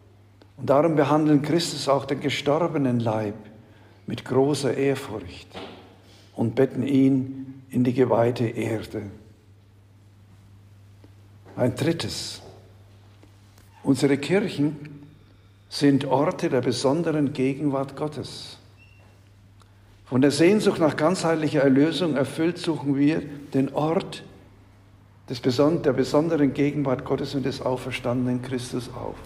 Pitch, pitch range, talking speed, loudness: 130 Hz, 100-145 Hz, 100 wpm, -23 LUFS